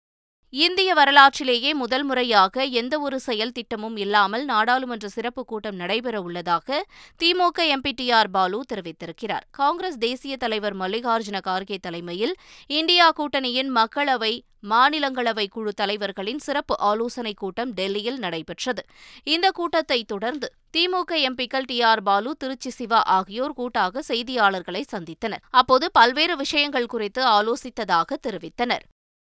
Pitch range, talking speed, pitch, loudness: 210-275 Hz, 110 wpm, 240 Hz, -22 LUFS